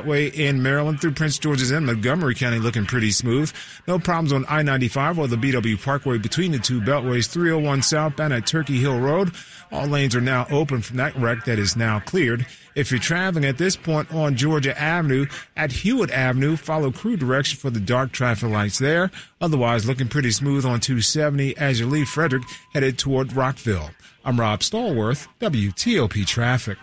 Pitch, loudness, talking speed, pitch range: 135 Hz, -21 LUFS, 185 wpm, 120-150 Hz